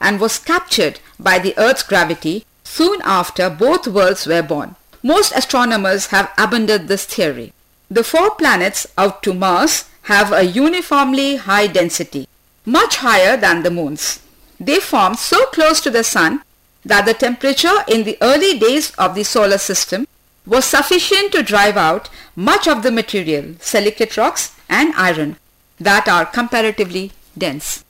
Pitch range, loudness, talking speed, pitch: 190-280 Hz, -14 LUFS, 150 wpm, 215 Hz